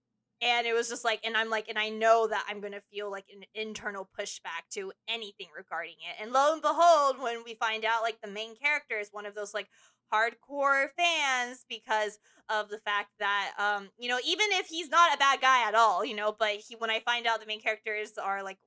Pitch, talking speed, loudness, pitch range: 225 Hz, 235 wpm, -29 LUFS, 210-250 Hz